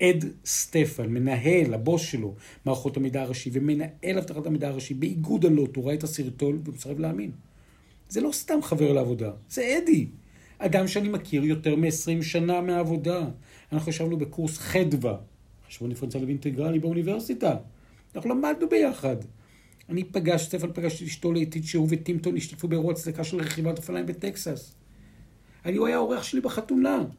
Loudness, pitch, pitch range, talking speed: -27 LUFS, 160 Hz, 135-175 Hz, 150 wpm